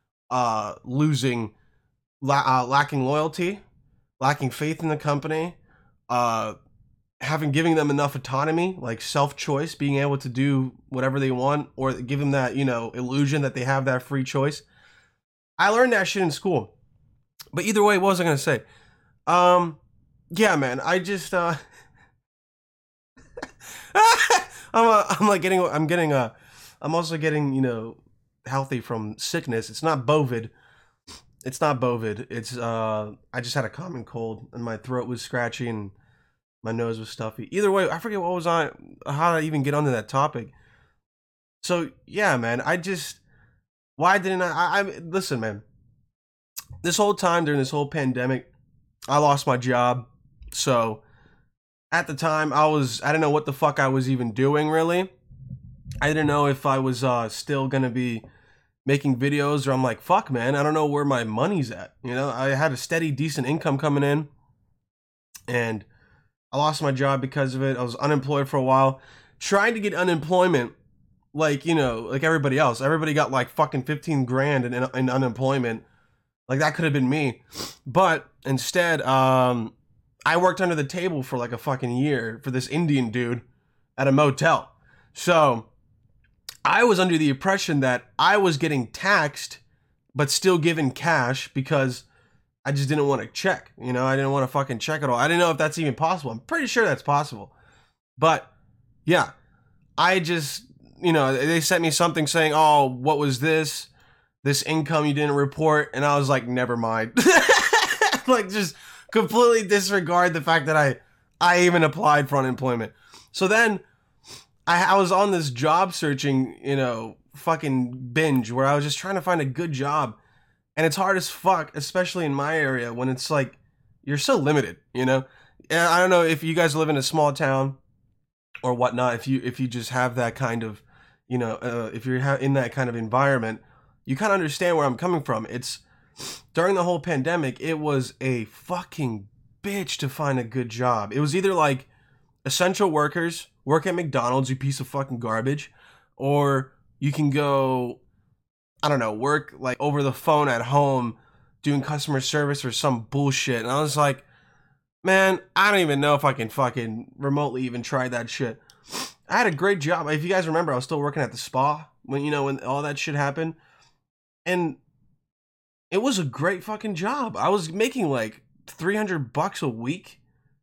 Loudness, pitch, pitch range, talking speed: -23 LUFS, 140 Hz, 125-160 Hz, 180 wpm